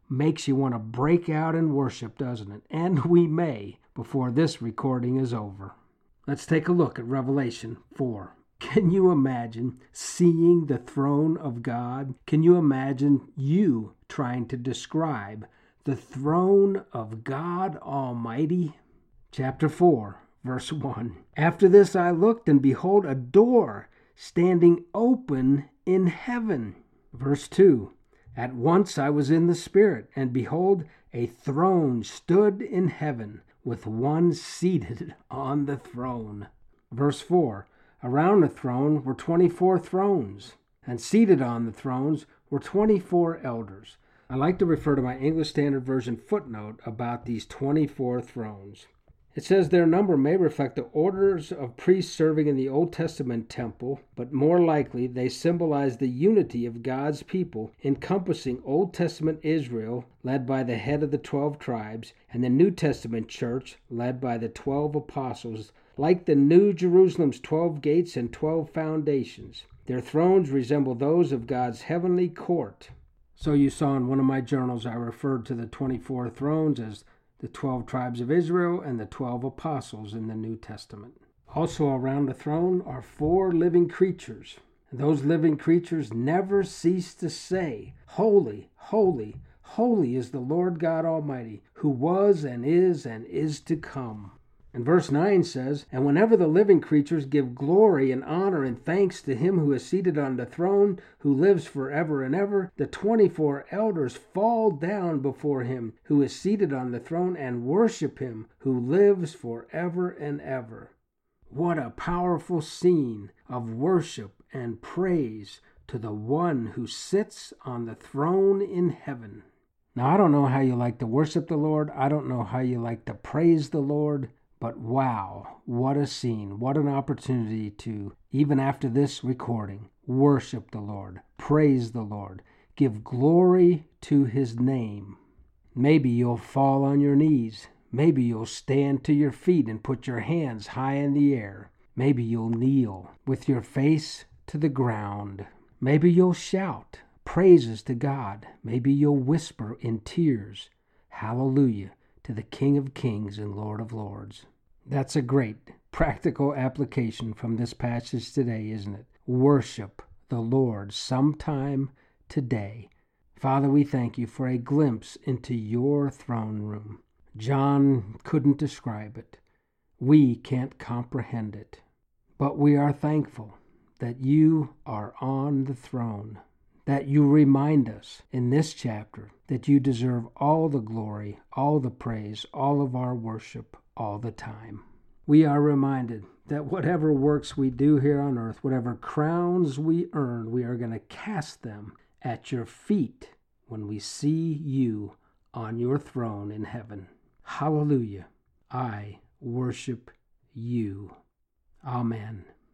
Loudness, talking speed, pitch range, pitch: -25 LUFS, 150 wpm, 120-160 Hz, 135 Hz